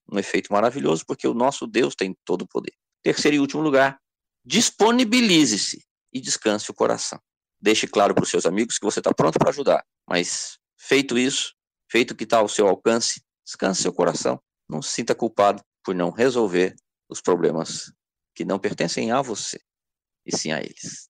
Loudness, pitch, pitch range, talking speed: -22 LUFS, 125 Hz, 100-155 Hz, 180 wpm